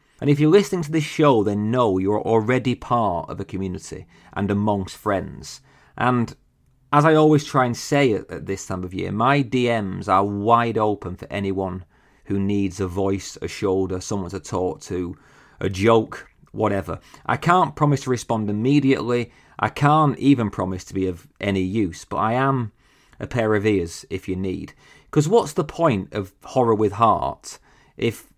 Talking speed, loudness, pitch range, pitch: 180 wpm, -21 LUFS, 95-130 Hz, 105 Hz